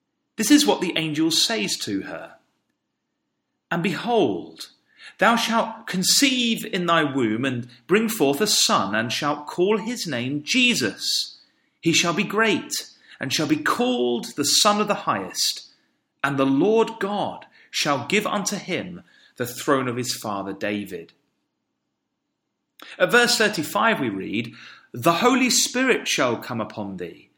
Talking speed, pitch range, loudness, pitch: 145 wpm, 135-225 Hz, -21 LUFS, 180 Hz